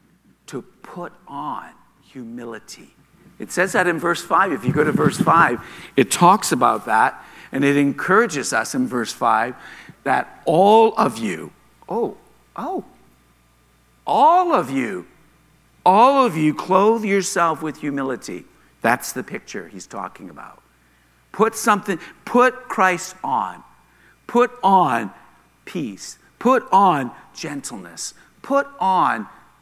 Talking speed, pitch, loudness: 125 wpm, 170 Hz, -19 LUFS